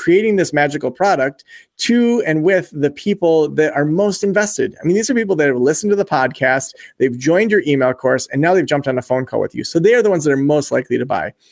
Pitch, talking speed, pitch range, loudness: 160 Hz, 260 wpm, 140-205 Hz, -16 LUFS